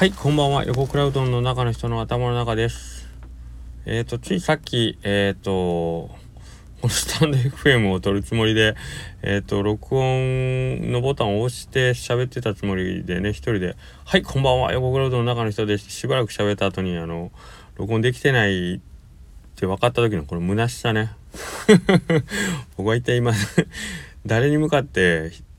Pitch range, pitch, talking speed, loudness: 95-130 Hz, 115 Hz, 330 characters per minute, -21 LUFS